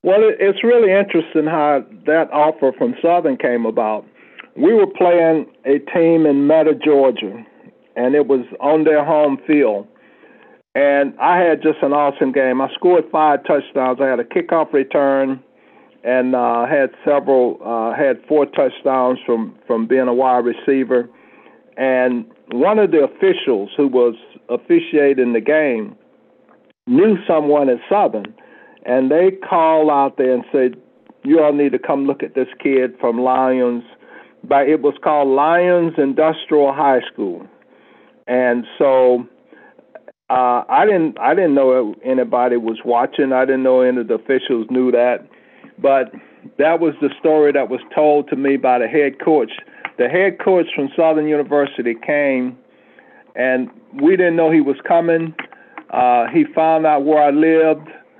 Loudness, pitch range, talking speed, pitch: -16 LUFS, 130-160 Hz, 155 wpm, 145 Hz